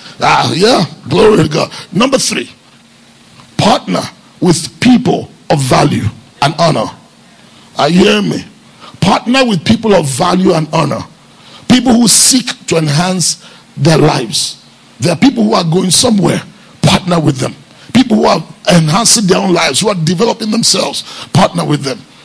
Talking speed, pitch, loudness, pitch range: 150 wpm, 180 Hz, -10 LUFS, 160-220 Hz